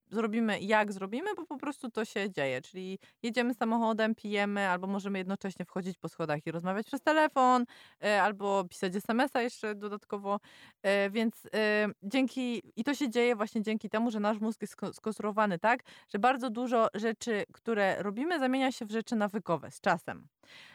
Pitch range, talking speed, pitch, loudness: 200-240 Hz, 160 wpm, 215 Hz, -32 LUFS